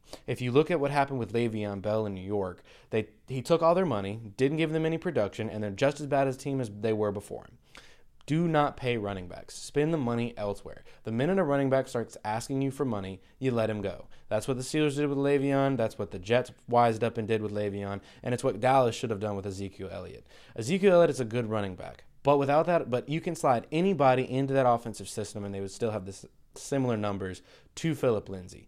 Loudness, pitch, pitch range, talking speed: -29 LUFS, 120 Hz, 105-140 Hz, 245 wpm